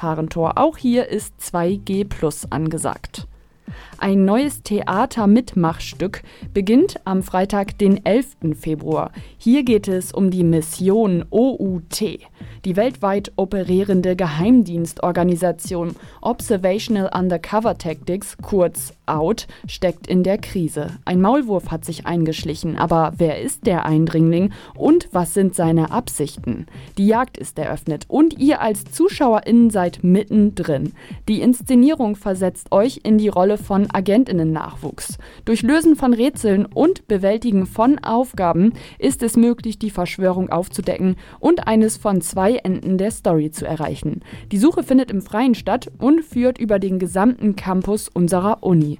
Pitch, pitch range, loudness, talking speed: 195 Hz, 175-225 Hz, -18 LUFS, 130 wpm